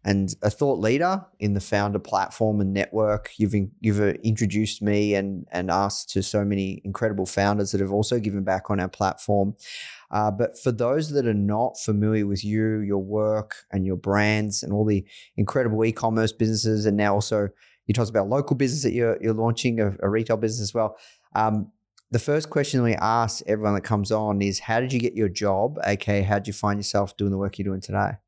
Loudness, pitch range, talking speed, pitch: -24 LUFS, 100-110 Hz, 205 wpm, 105 Hz